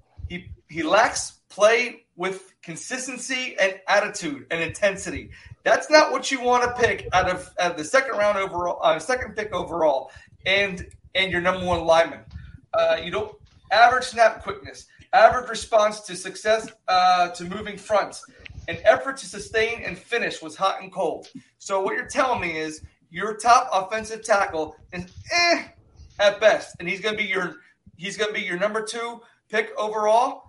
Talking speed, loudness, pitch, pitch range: 170 wpm, -22 LUFS, 205 Hz, 180-235 Hz